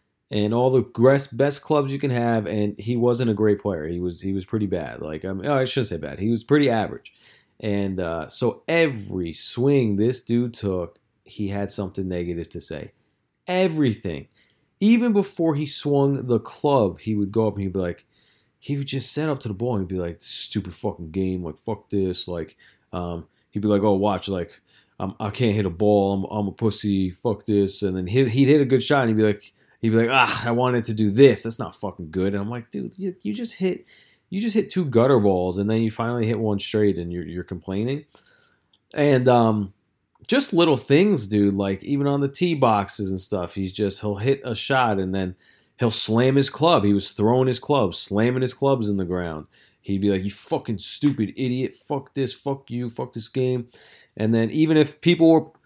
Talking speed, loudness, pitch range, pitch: 220 wpm, -22 LUFS, 100-135 Hz, 110 Hz